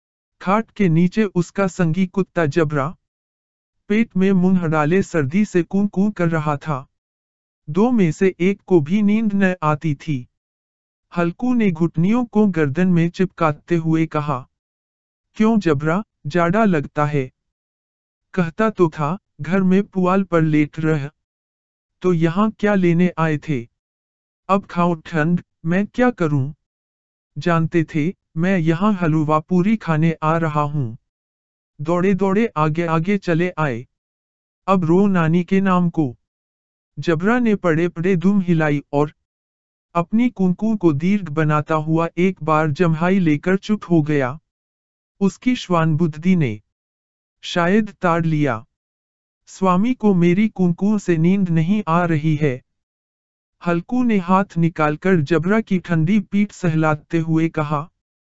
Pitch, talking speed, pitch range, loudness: 165 Hz, 135 wpm, 145-190 Hz, -19 LUFS